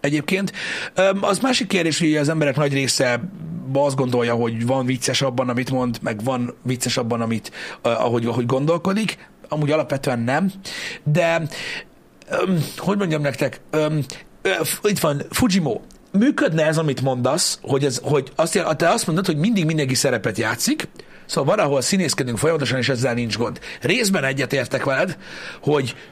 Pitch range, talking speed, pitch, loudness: 130-175 Hz, 145 wpm, 150 Hz, -21 LUFS